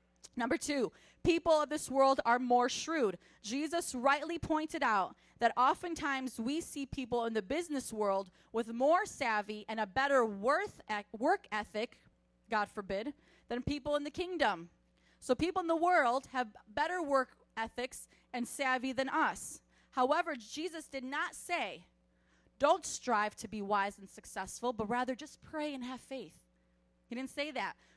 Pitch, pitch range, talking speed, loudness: 255 Hz, 215-300 Hz, 160 wpm, -35 LUFS